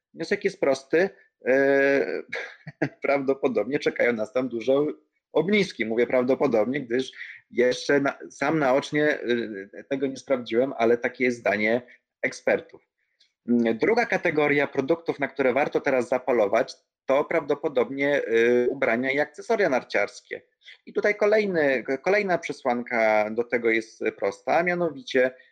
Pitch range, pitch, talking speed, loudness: 120-155 Hz, 135 Hz, 115 wpm, -24 LUFS